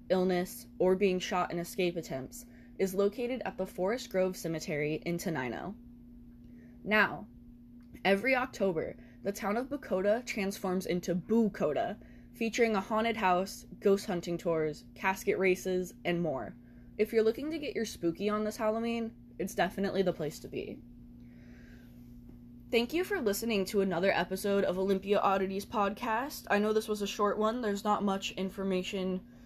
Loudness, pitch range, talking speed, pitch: -32 LUFS, 155-210 Hz, 155 wpm, 190 Hz